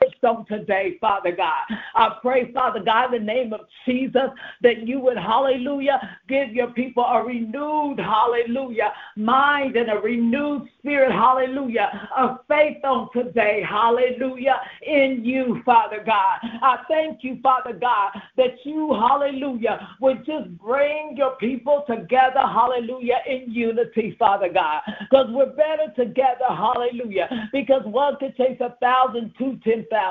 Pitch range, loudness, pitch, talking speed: 230-270 Hz, -21 LUFS, 250 Hz, 140 wpm